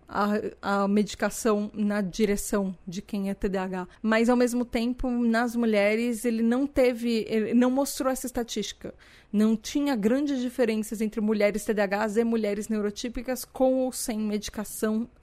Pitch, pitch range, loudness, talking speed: 225 Hz, 210-245 Hz, -27 LUFS, 145 wpm